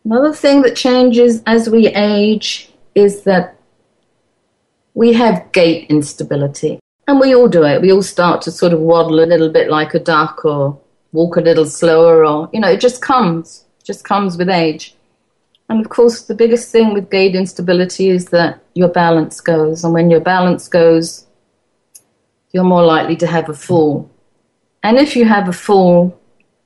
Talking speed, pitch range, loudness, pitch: 180 wpm, 160-215 Hz, -12 LUFS, 175 Hz